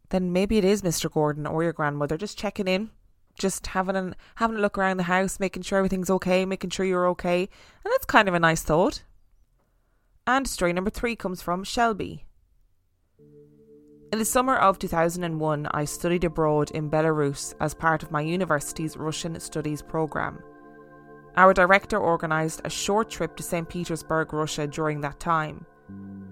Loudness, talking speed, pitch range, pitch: -25 LUFS, 170 wpm, 150-190 Hz, 165 Hz